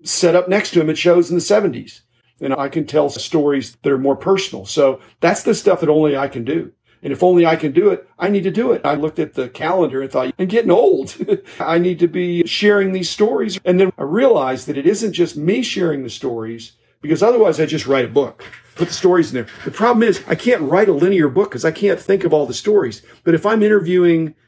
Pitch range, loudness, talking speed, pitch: 145-195 Hz, -16 LUFS, 250 wpm, 170 Hz